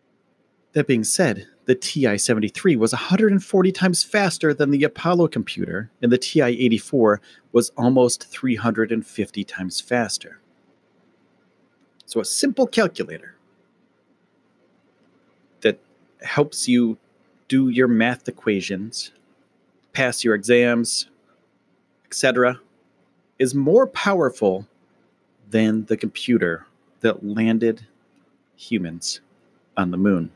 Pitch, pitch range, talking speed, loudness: 120 Hz, 110-140 Hz, 95 wpm, -21 LUFS